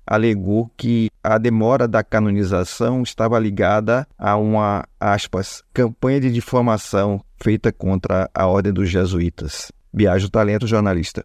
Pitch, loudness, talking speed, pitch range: 105 Hz, -19 LUFS, 125 wpm, 100-115 Hz